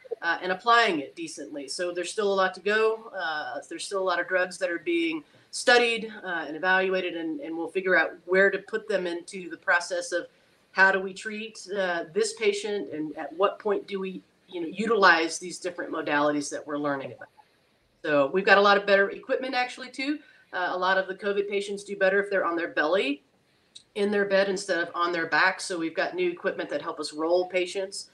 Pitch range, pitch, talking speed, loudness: 170-205 Hz, 190 Hz, 220 wpm, -26 LUFS